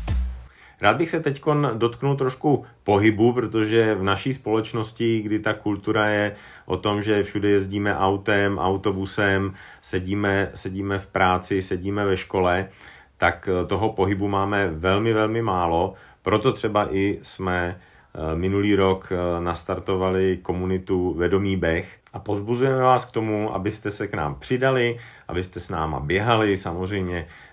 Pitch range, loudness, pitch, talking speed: 95-110 Hz, -23 LUFS, 100 Hz, 135 wpm